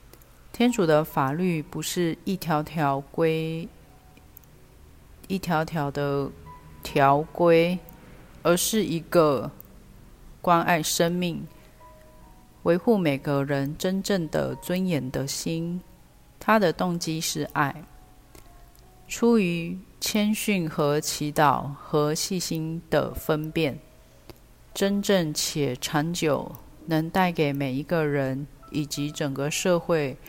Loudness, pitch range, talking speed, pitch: -25 LUFS, 140-175 Hz, 145 characters per minute, 155 Hz